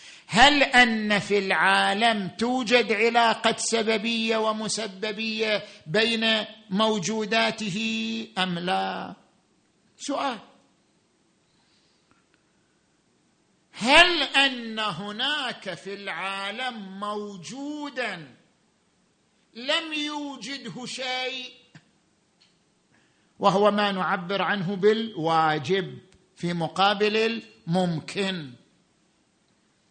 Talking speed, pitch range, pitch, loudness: 60 wpm, 195-235 Hz, 215 Hz, -24 LUFS